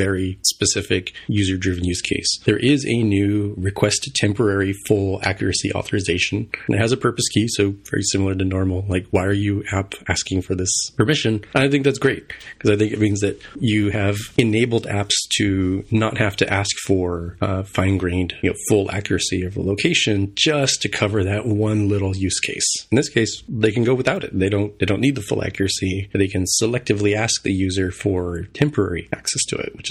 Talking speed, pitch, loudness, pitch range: 200 wpm, 100 Hz, -20 LUFS, 95-110 Hz